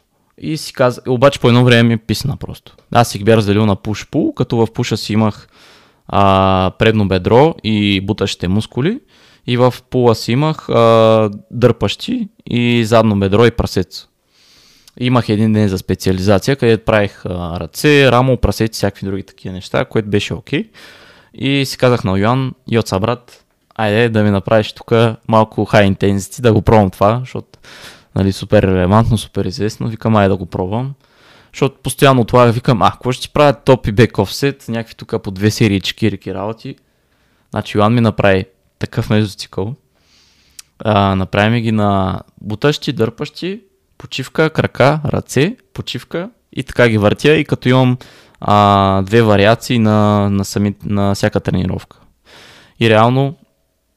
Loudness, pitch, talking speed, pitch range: -14 LUFS, 110 Hz, 160 wpm, 100-125 Hz